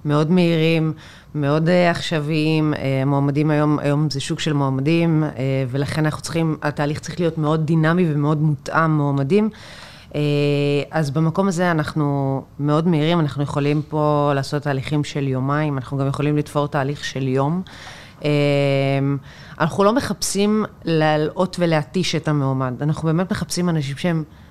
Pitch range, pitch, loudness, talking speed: 145-160 Hz, 150 Hz, -20 LUFS, 145 wpm